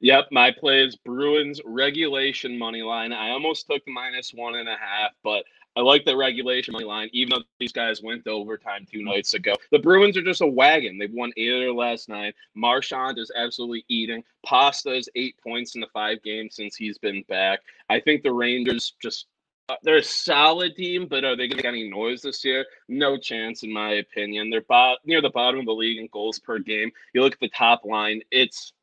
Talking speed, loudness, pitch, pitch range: 220 wpm, -22 LUFS, 120 Hz, 110-130 Hz